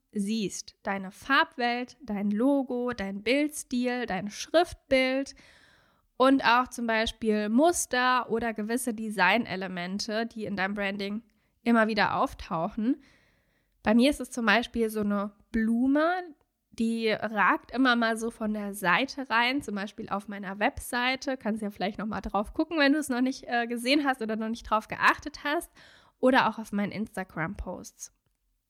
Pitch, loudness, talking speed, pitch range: 230 Hz, -28 LUFS, 155 wpm, 205-255 Hz